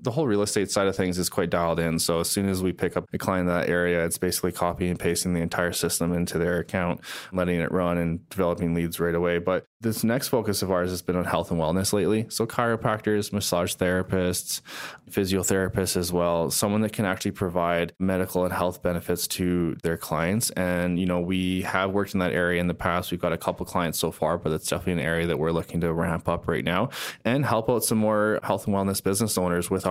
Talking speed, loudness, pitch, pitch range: 235 wpm, -25 LUFS, 90 Hz, 85-95 Hz